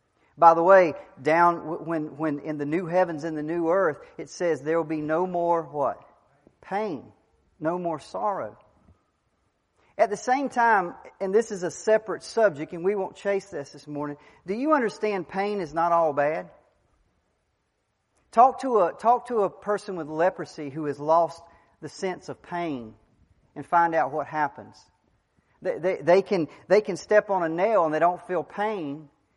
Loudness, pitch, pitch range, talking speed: -25 LUFS, 170 Hz, 155-195 Hz, 180 wpm